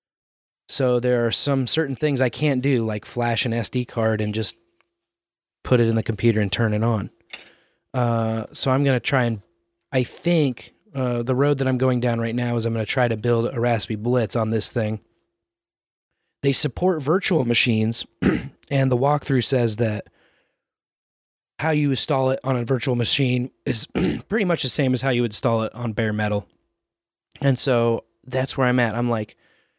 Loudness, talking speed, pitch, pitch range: -21 LUFS, 190 wpm, 120 Hz, 115-135 Hz